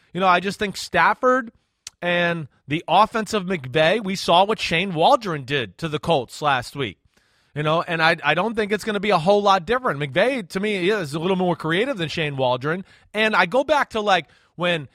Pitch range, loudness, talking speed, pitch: 160-215 Hz, -21 LUFS, 220 wpm, 180 Hz